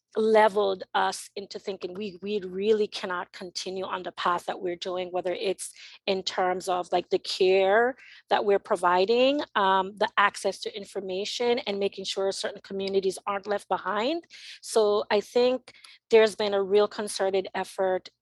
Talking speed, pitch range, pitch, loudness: 160 wpm, 190-210 Hz, 200 Hz, -27 LUFS